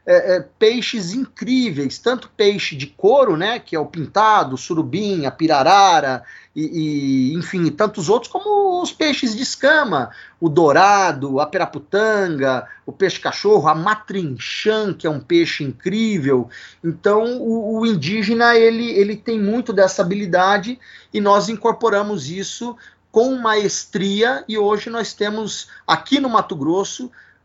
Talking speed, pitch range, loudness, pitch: 145 wpm, 170-230 Hz, -18 LUFS, 205 Hz